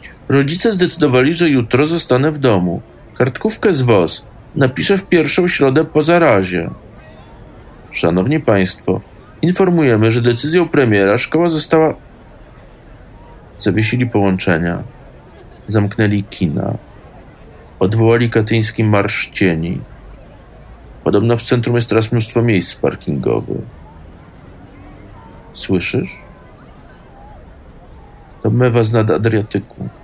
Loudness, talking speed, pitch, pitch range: -14 LUFS, 90 wpm, 115 Hz, 100-150 Hz